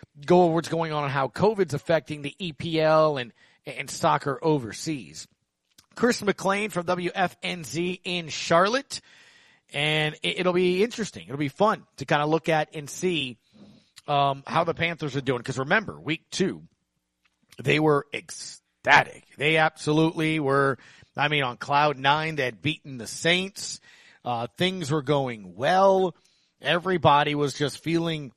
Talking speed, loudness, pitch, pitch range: 150 wpm, -25 LUFS, 155 Hz, 140-180 Hz